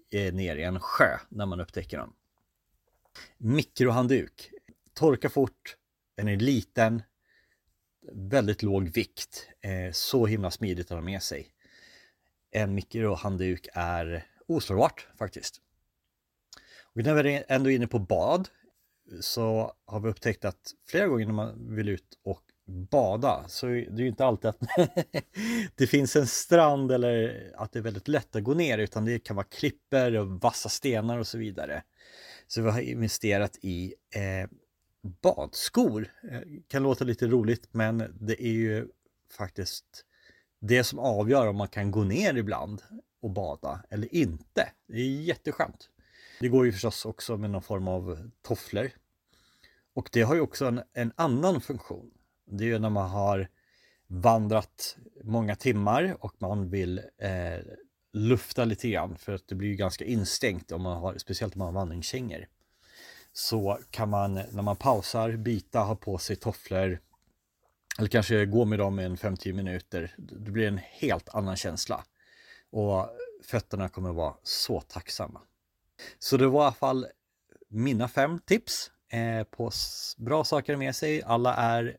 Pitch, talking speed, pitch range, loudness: 110 Hz, 155 wpm, 95-125 Hz, -29 LUFS